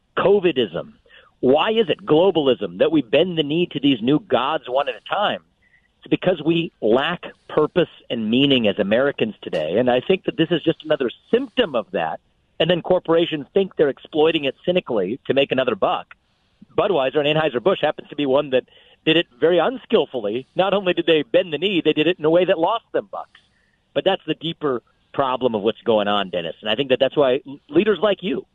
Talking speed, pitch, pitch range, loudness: 210 wpm, 160 Hz, 140-185 Hz, -20 LUFS